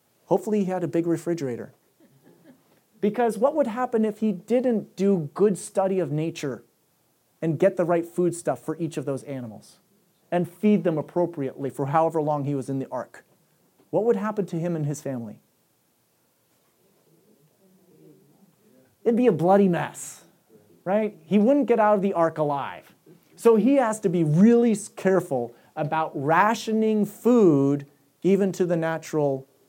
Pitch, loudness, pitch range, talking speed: 175 Hz, -24 LUFS, 155-210 Hz, 155 wpm